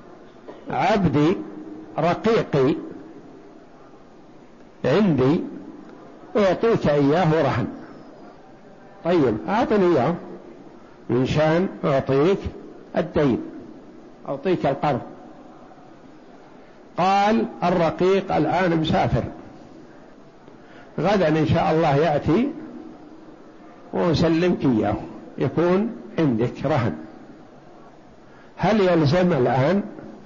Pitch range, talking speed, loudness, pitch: 155-215 Hz, 65 wpm, -21 LUFS, 175 Hz